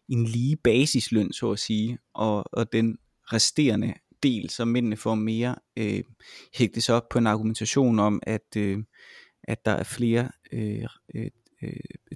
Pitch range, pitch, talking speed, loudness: 110-120 Hz, 115 Hz, 160 wpm, -26 LUFS